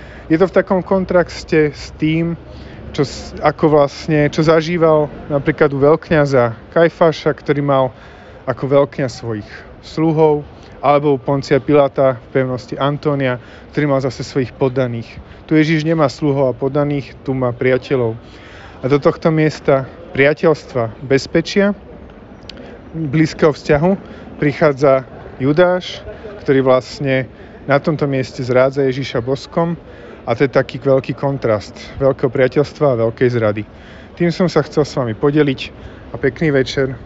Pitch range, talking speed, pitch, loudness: 130-155 Hz, 135 wpm, 140 Hz, -16 LUFS